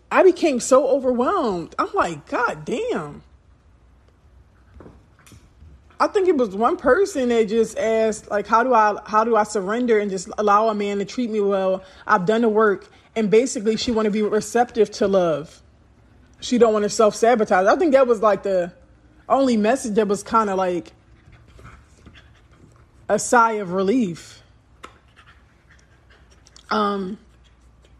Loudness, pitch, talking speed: -20 LUFS, 210 Hz, 150 wpm